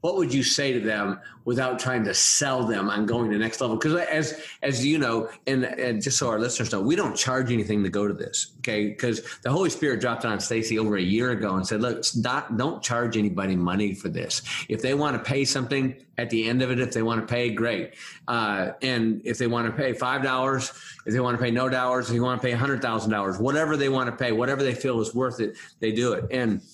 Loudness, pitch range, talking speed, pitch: -25 LUFS, 110-130 Hz, 265 wpm, 120 Hz